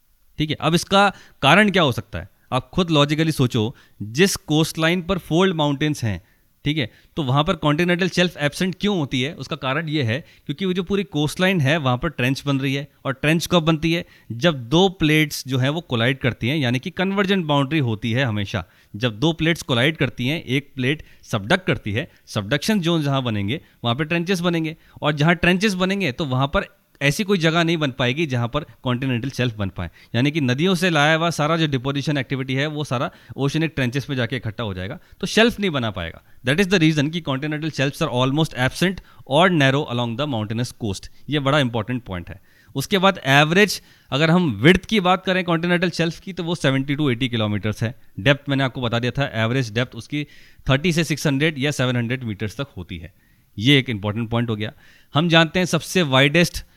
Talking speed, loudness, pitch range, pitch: 210 wpm, -20 LUFS, 125-170 Hz, 145 Hz